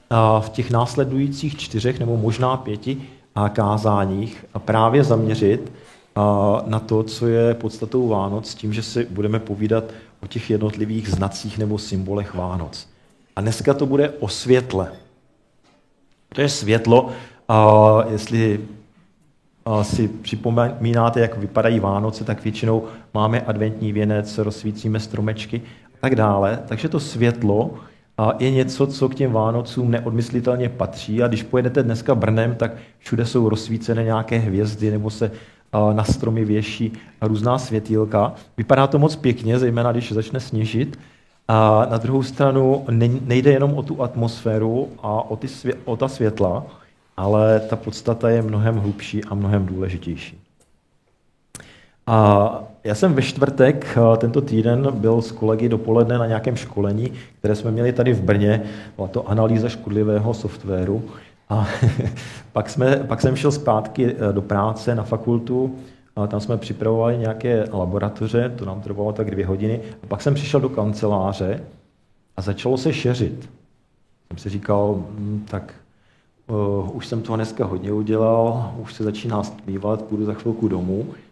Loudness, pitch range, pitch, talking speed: -20 LUFS, 105-120 Hz, 110 Hz, 140 wpm